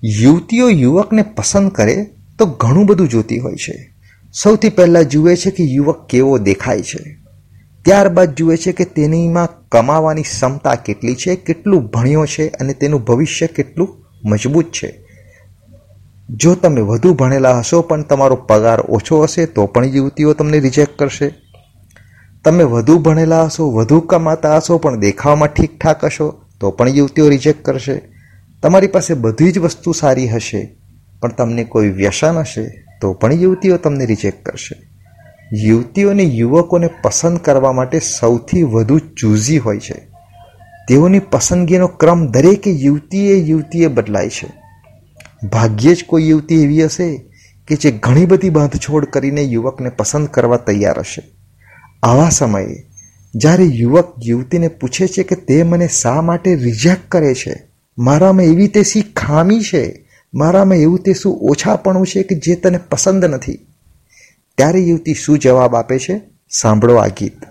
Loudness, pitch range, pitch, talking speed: -12 LUFS, 115-170 Hz, 150 Hz, 145 wpm